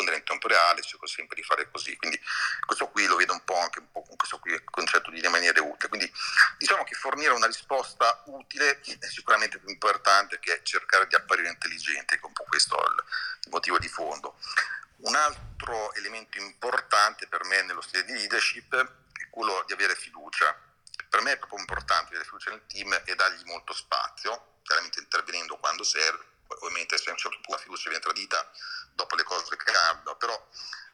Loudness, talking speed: -26 LUFS, 180 wpm